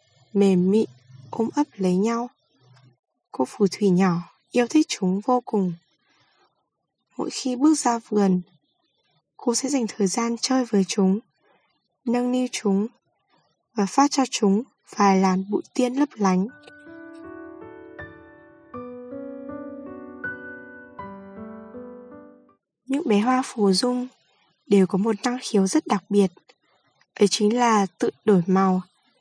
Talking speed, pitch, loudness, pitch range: 125 wpm, 225 Hz, -22 LUFS, 195-265 Hz